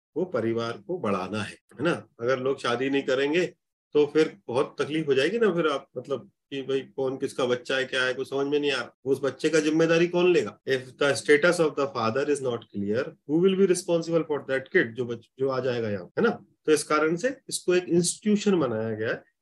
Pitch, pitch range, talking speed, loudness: 140 Hz, 130-170 Hz, 225 wpm, -26 LUFS